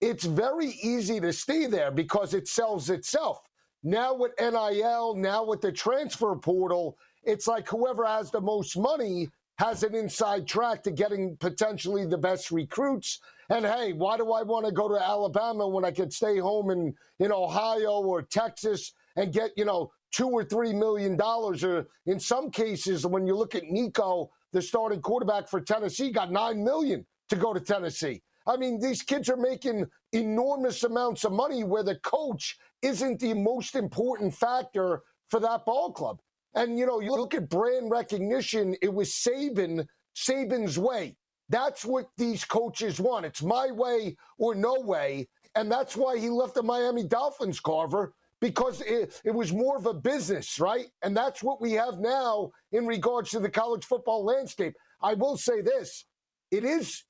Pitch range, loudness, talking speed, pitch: 195-245 Hz, -29 LUFS, 175 wpm, 220 Hz